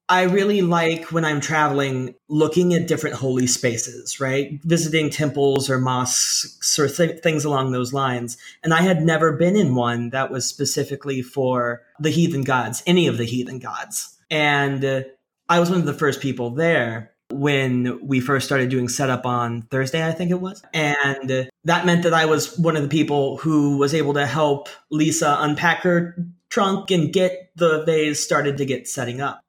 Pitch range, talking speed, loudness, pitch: 130-165 Hz, 185 wpm, -20 LUFS, 145 Hz